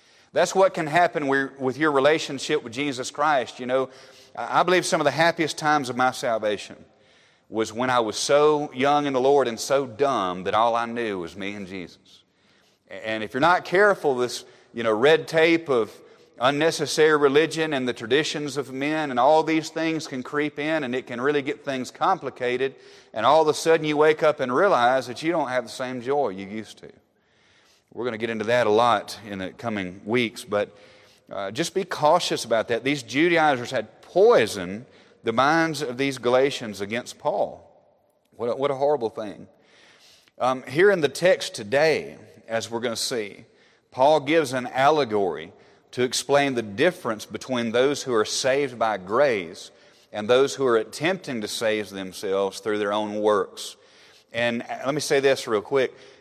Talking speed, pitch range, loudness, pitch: 185 wpm, 115-155 Hz, -23 LUFS, 135 Hz